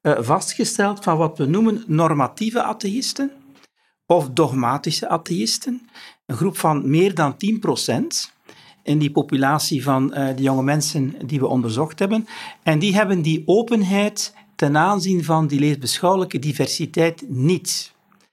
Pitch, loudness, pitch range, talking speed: 165 Hz, -20 LUFS, 145-205 Hz, 130 wpm